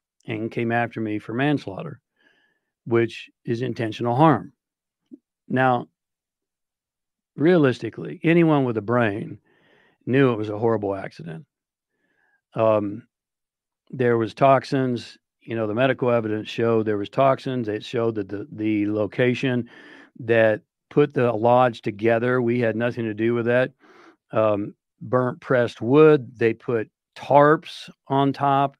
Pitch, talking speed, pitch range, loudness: 120 Hz, 130 wpm, 110-130 Hz, -22 LUFS